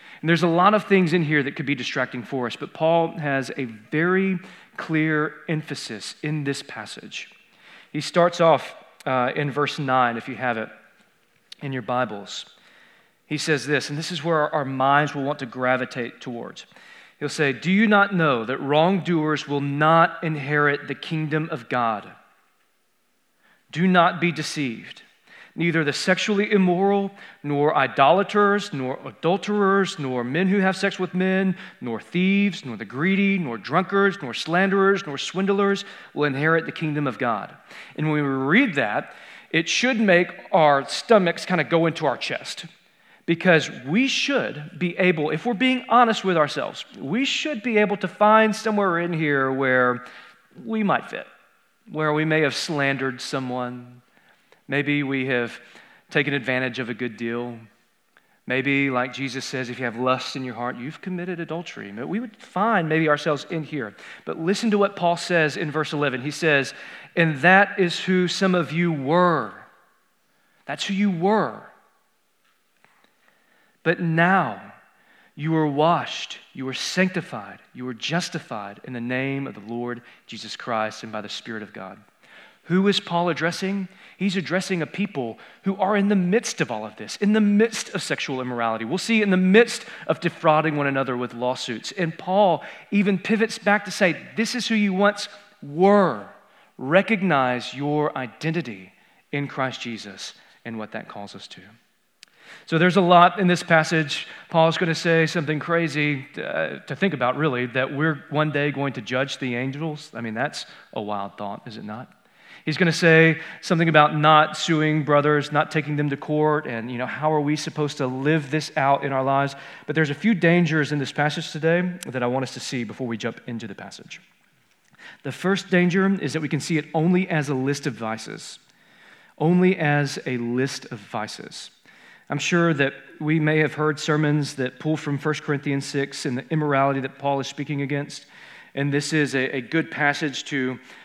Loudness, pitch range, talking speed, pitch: -22 LUFS, 135-180 Hz, 180 wpm, 155 Hz